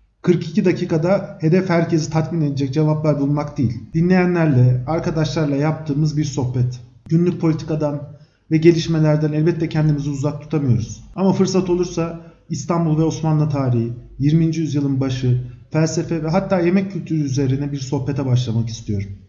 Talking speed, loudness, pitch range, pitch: 130 wpm, -19 LUFS, 140-165 Hz, 155 Hz